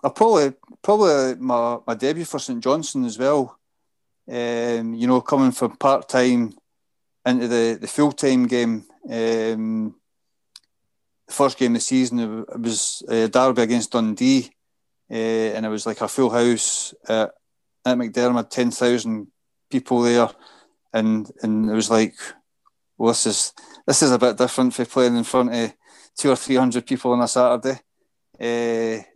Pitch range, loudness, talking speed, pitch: 115-130 Hz, -21 LUFS, 165 wpm, 120 Hz